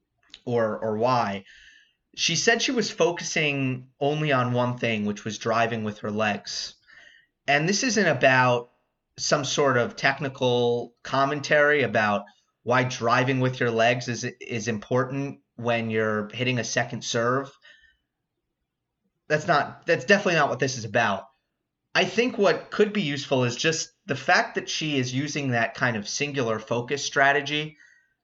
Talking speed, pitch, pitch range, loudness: 150 wpm, 130 Hz, 120-155 Hz, -24 LUFS